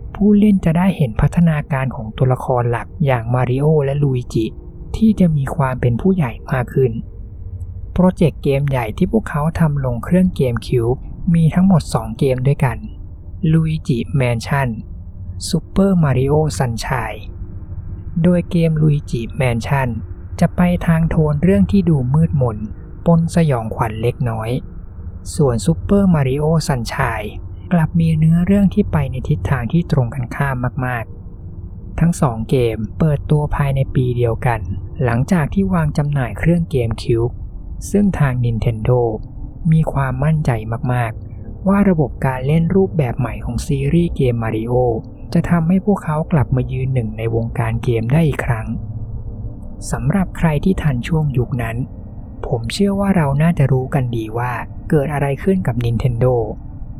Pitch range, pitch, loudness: 115-160 Hz, 130 Hz, -17 LUFS